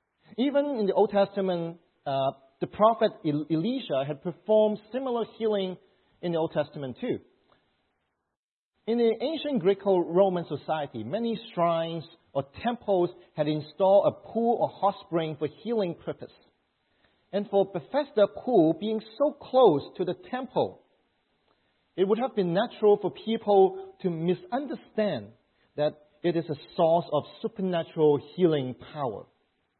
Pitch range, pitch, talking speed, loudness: 155-215 Hz, 185 Hz, 130 wpm, -27 LUFS